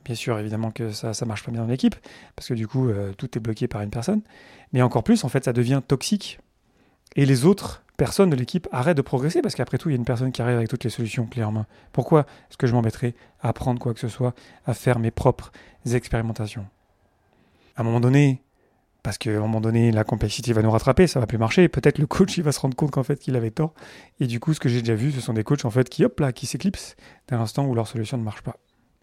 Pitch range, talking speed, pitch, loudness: 115-140 Hz, 270 wpm, 125 Hz, -23 LUFS